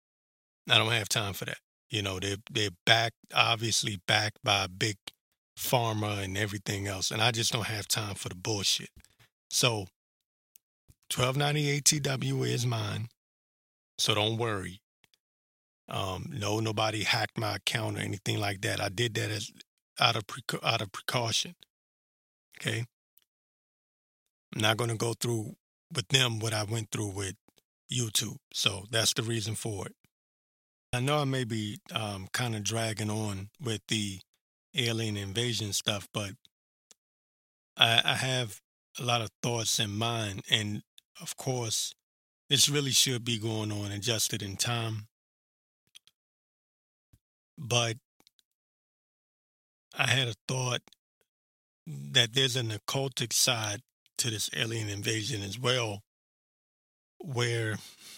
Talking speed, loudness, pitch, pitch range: 135 wpm, -29 LUFS, 110 Hz, 105-120 Hz